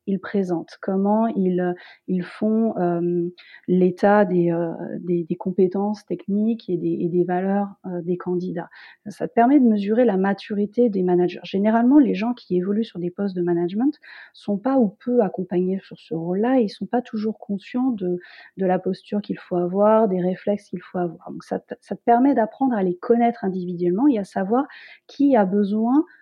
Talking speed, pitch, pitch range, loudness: 190 wpm, 195 Hz, 180-225 Hz, -22 LUFS